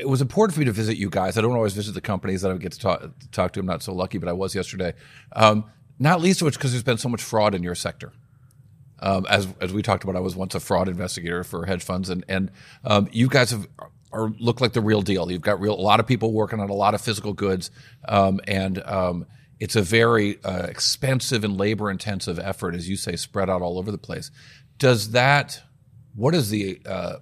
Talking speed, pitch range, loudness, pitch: 250 wpm, 95-125 Hz, -23 LUFS, 105 Hz